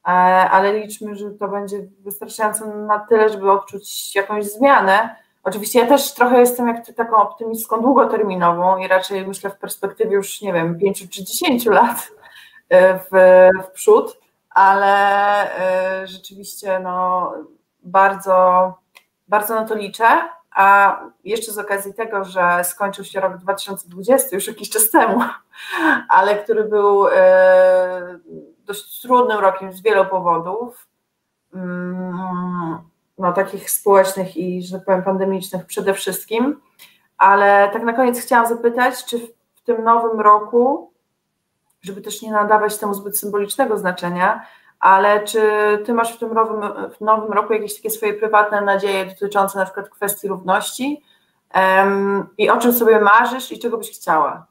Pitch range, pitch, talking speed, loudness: 190-220 Hz, 200 Hz, 140 wpm, -16 LUFS